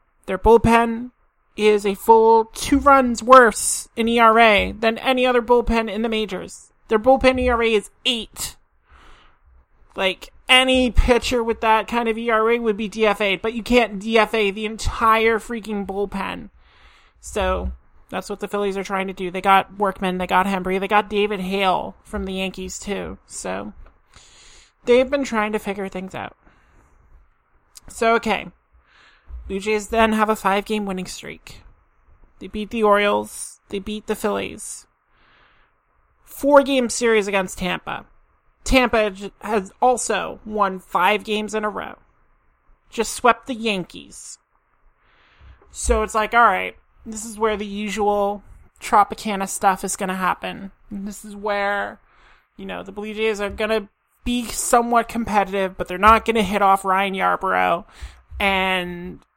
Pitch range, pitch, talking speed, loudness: 195-225 Hz, 210 Hz, 150 wpm, -19 LUFS